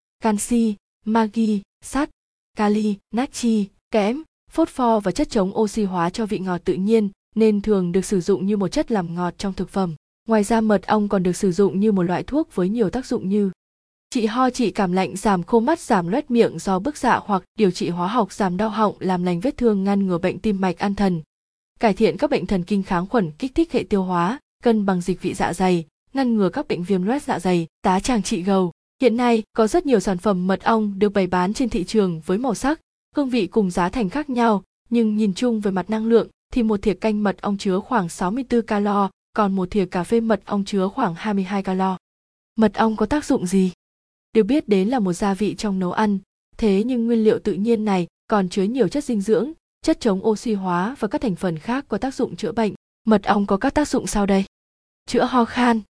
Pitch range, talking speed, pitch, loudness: 190-230 Hz, 235 wpm, 210 Hz, -21 LUFS